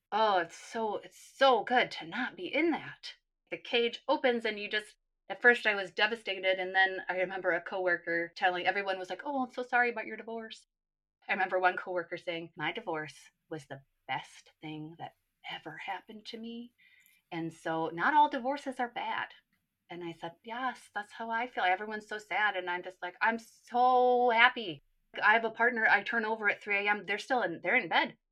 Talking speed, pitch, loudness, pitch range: 205 wpm, 210 Hz, -31 LUFS, 180-240 Hz